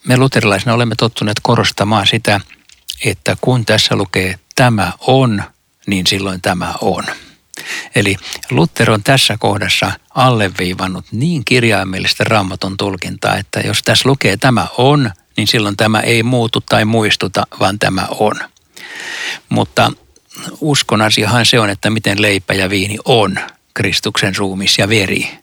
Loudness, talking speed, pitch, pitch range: -13 LUFS, 130 wpm, 110 Hz, 100-120 Hz